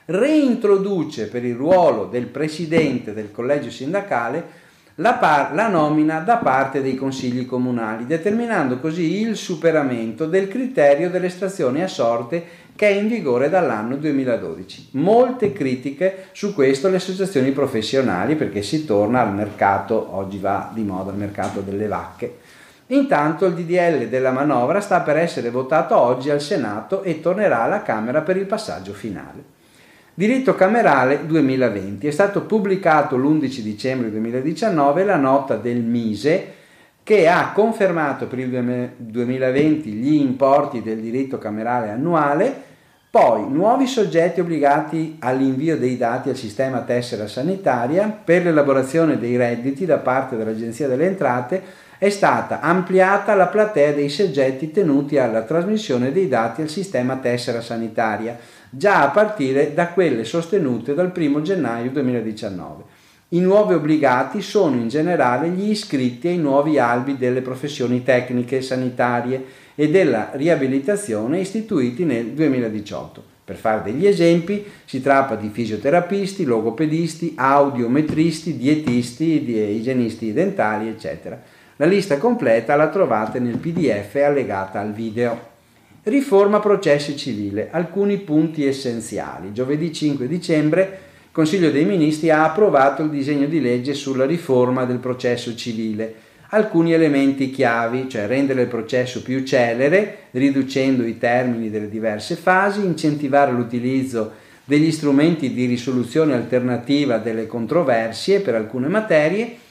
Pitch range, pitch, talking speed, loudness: 120-170 Hz, 140 Hz, 130 wpm, -19 LUFS